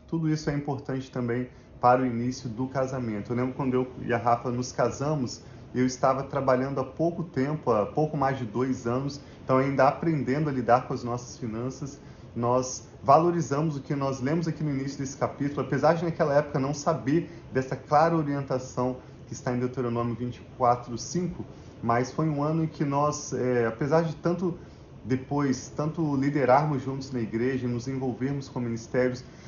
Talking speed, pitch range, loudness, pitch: 175 wpm, 125-145 Hz, -27 LUFS, 130 Hz